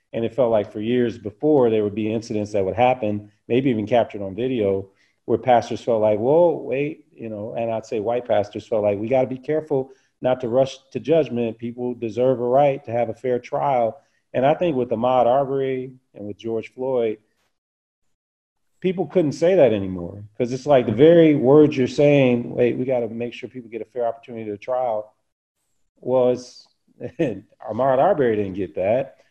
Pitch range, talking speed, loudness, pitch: 110-130 Hz, 190 wpm, -21 LUFS, 120 Hz